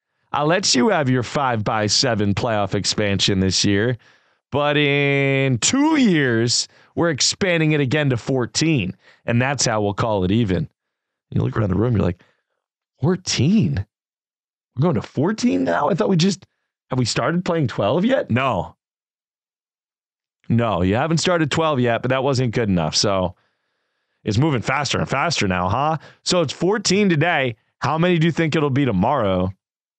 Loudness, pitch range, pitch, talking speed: -19 LUFS, 110-160 Hz, 130 Hz, 170 wpm